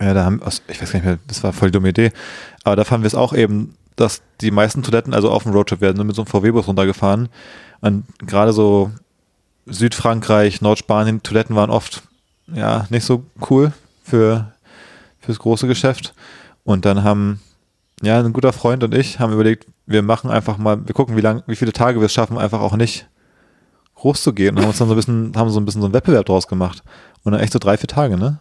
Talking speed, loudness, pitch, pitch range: 225 wpm, -16 LUFS, 110 Hz, 100-120 Hz